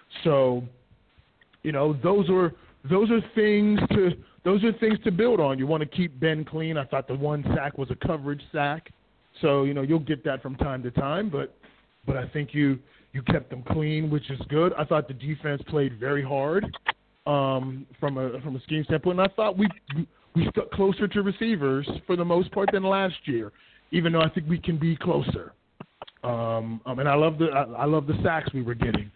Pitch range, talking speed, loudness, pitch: 135-175 Hz, 215 wpm, -26 LUFS, 150 Hz